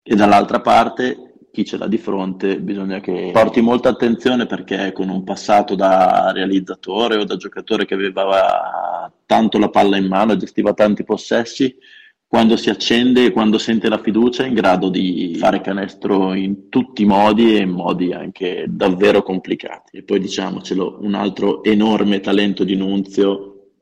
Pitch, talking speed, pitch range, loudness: 100 Hz, 165 wpm, 95-110 Hz, -16 LUFS